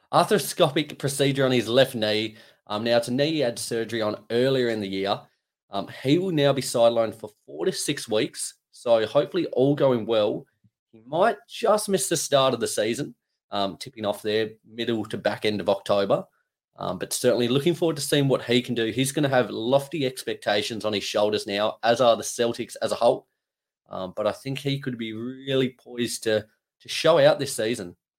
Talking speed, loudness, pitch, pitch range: 205 wpm, -24 LUFS, 120 Hz, 110-135 Hz